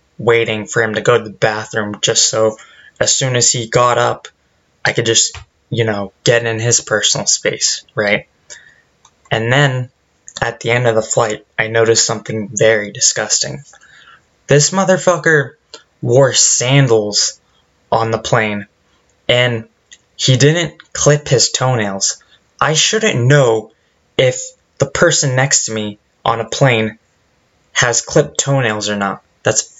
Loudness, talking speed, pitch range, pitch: -14 LUFS, 145 wpm, 110-140 Hz, 115 Hz